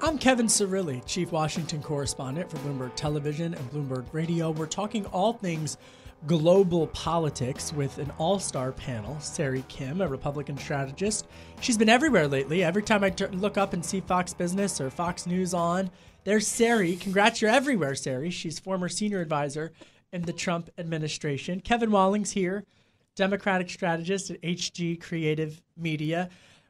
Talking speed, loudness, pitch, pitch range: 155 wpm, -27 LUFS, 175 Hz, 150-195 Hz